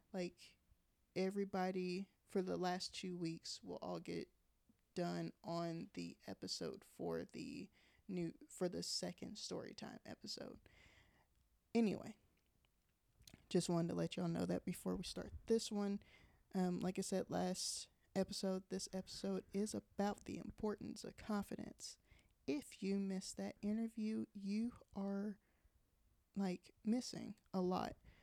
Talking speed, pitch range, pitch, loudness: 130 wpm, 170-205 Hz, 190 Hz, -45 LUFS